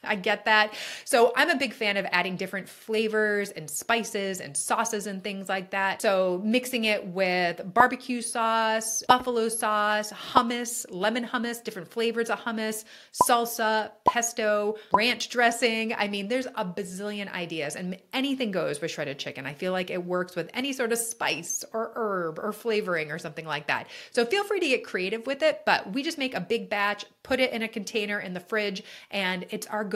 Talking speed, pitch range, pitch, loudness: 190 wpm, 195-235 Hz, 215 Hz, -27 LUFS